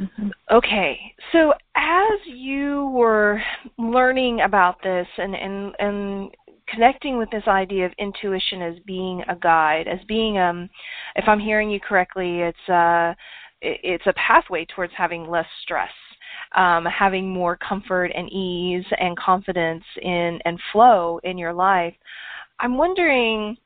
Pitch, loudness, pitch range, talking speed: 195 Hz, -21 LUFS, 175-225 Hz, 135 wpm